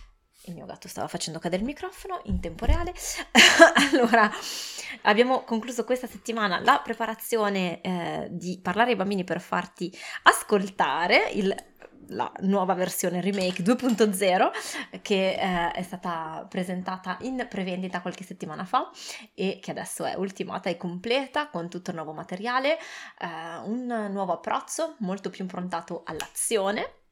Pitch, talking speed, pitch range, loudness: 195 Hz, 140 wpm, 180-235 Hz, -25 LUFS